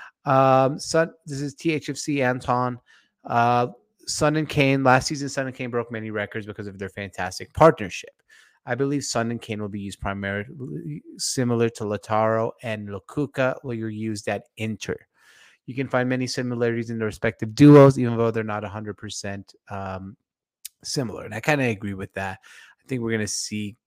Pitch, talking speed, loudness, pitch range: 115 Hz, 180 wpm, -23 LUFS, 105-130 Hz